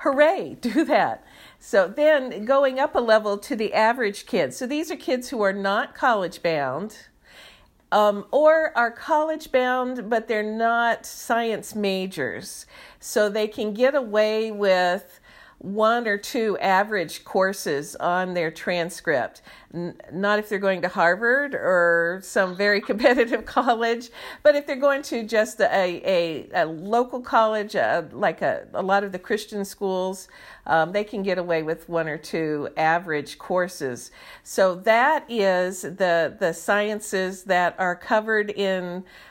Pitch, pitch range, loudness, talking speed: 210 Hz, 185-240 Hz, -23 LUFS, 155 wpm